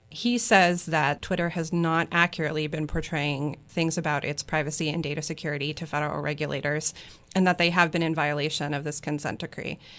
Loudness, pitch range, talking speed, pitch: -26 LUFS, 150-170 Hz, 180 wpm, 155 Hz